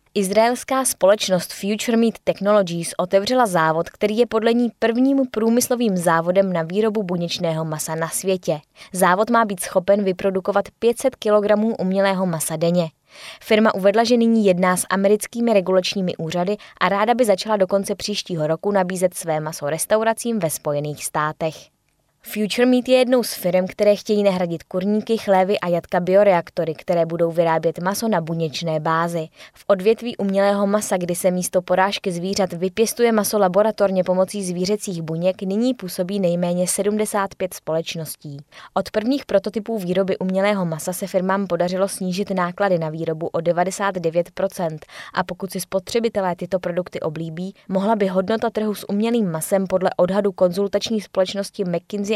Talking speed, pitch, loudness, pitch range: 150 wpm, 190 Hz, -20 LUFS, 175-210 Hz